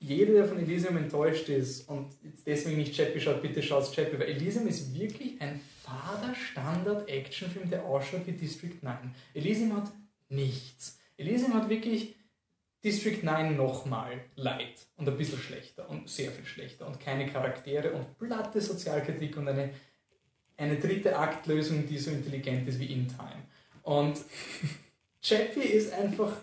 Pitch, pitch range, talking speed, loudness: 150 Hz, 140-195 Hz, 150 wpm, -32 LUFS